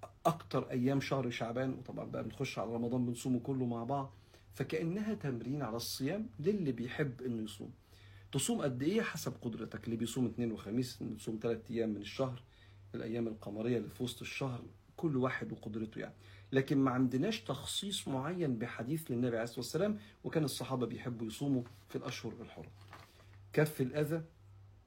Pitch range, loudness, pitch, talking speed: 115-135 Hz, -38 LUFS, 120 Hz, 155 wpm